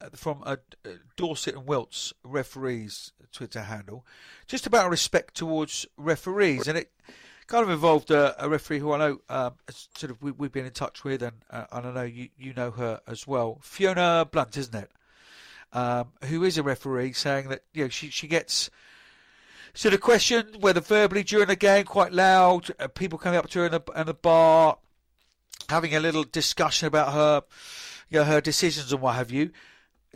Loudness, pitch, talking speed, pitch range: -25 LUFS, 150 Hz, 195 wpm, 130-175 Hz